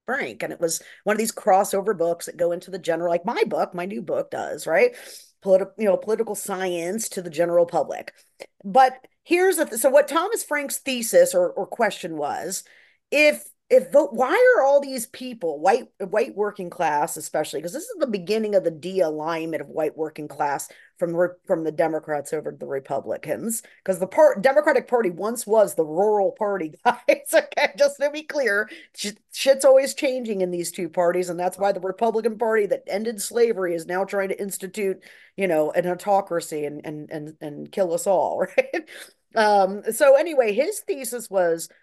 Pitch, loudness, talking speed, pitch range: 200 Hz, -22 LUFS, 190 wpm, 175-265 Hz